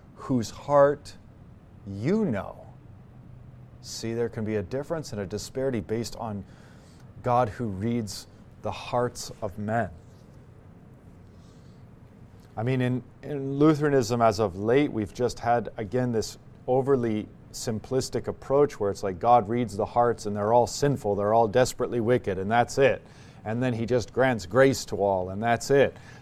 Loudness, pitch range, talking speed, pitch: -26 LUFS, 105-125 Hz, 155 wpm, 115 Hz